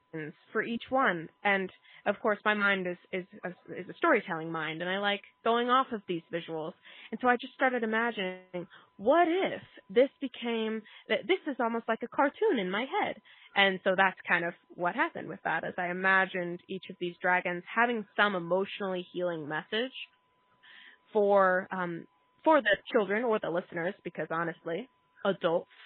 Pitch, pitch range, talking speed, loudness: 195 Hz, 180-230 Hz, 170 wpm, -30 LUFS